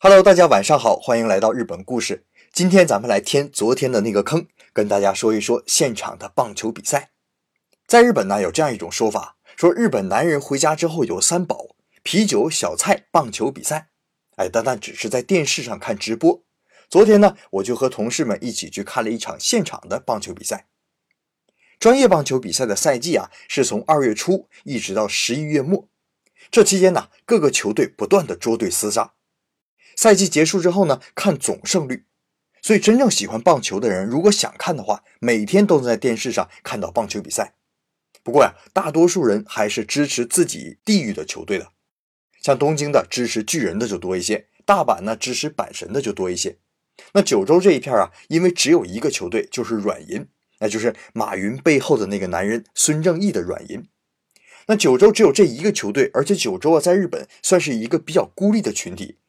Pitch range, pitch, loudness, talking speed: 125-205 Hz, 175 Hz, -18 LUFS, 300 characters per minute